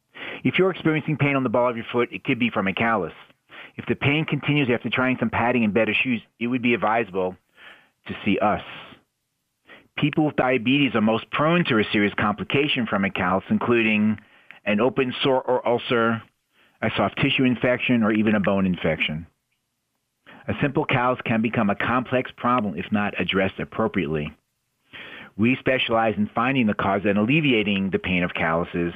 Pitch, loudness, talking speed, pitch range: 115 Hz, -22 LUFS, 180 wpm, 105-130 Hz